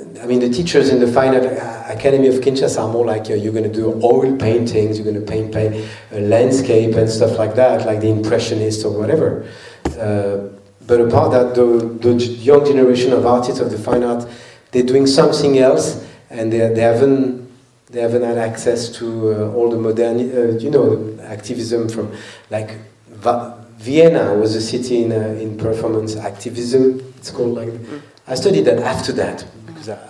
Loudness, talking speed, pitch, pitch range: -16 LUFS, 185 wpm, 115 Hz, 110-125 Hz